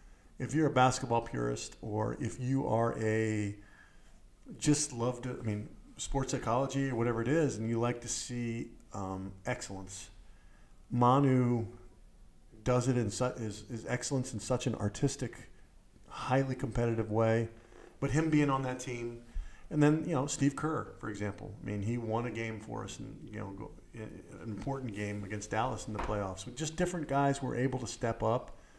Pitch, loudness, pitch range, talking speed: 115 Hz, -34 LUFS, 105-130 Hz, 175 wpm